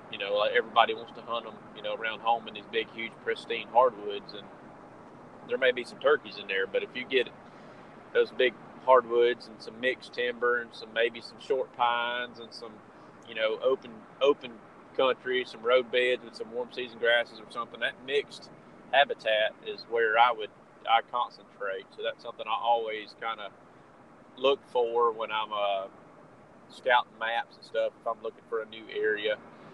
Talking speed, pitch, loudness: 185 wpm, 130 Hz, -29 LUFS